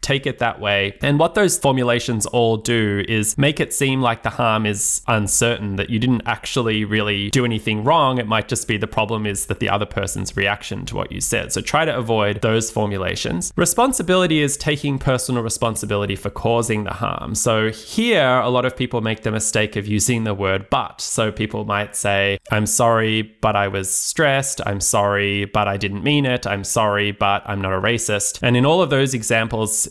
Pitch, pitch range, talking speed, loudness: 110 Hz, 105-125 Hz, 205 wpm, -19 LUFS